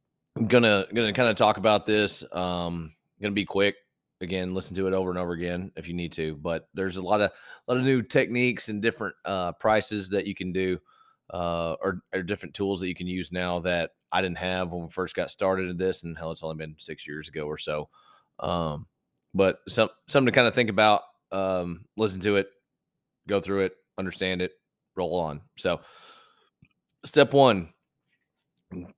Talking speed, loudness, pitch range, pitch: 195 wpm, -26 LUFS, 90-105 Hz, 95 Hz